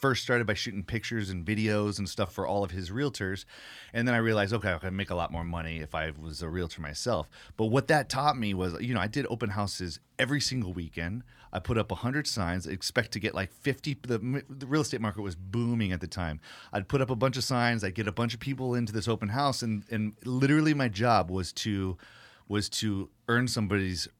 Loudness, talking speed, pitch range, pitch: -30 LUFS, 240 wpm, 95-125 Hz, 110 Hz